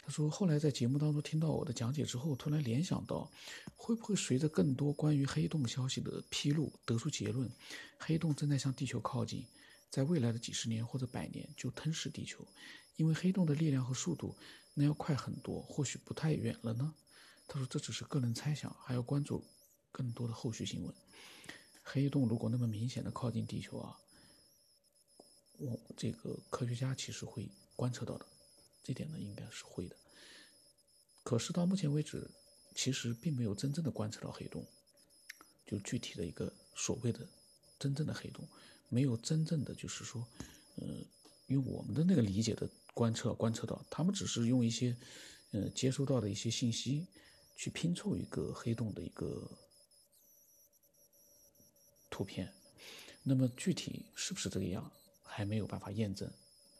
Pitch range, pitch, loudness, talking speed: 115-150 Hz, 130 Hz, -38 LUFS, 260 characters per minute